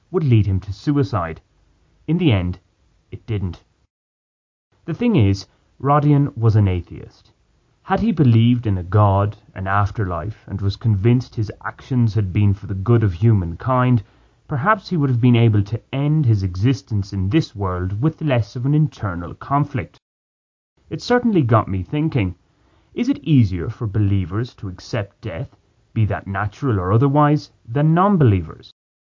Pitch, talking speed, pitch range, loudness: 110 Hz, 160 wpm, 100-135 Hz, -19 LUFS